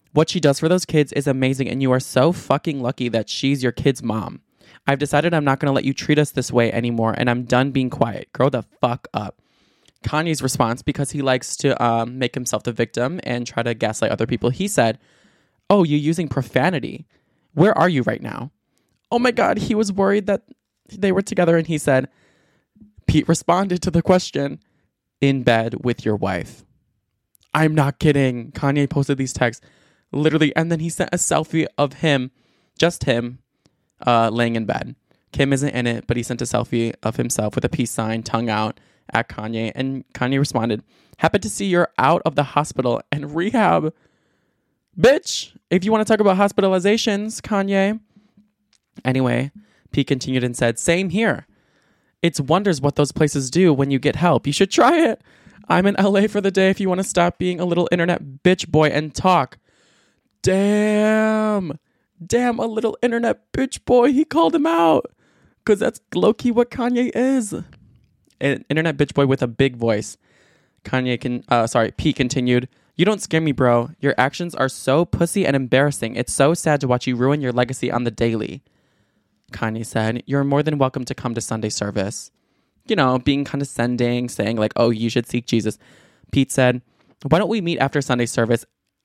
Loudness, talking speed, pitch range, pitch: -20 LUFS, 190 wpm, 120-175 Hz, 140 Hz